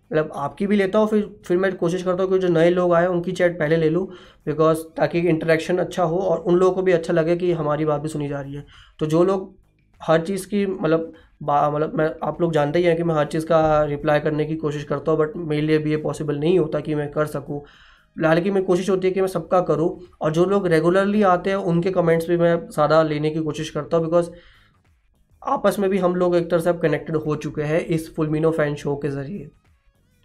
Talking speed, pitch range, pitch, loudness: 240 wpm, 150-180 Hz, 165 Hz, -21 LUFS